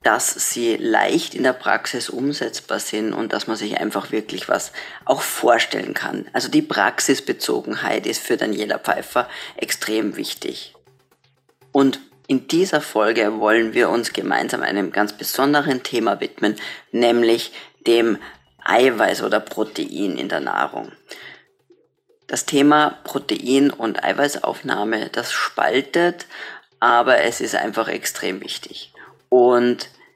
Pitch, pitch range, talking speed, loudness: 135 Hz, 120-175 Hz, 125 wpm, -20 LUFS